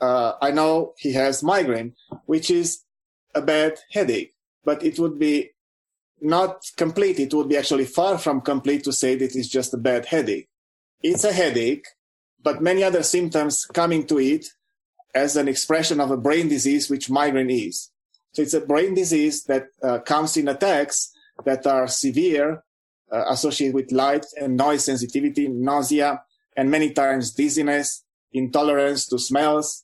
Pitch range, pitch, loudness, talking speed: 135-160 Hz, 145 Hz, -22 LUFS, 160 wpm